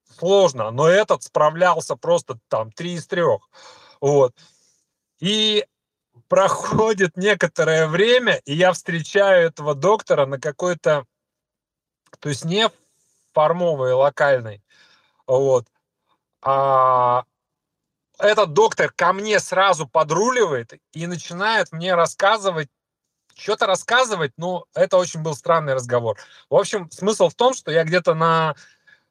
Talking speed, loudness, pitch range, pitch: 115 wpm, -19 LUFS, 150-210 Hz, 170 Hz